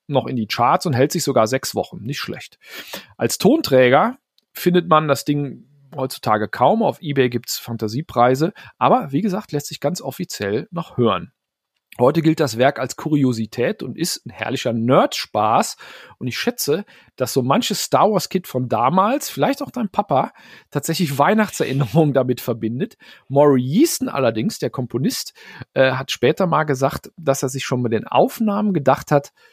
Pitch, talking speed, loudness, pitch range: 145 Hz, 165 wpm, -19 LUFS, 130-180 Hz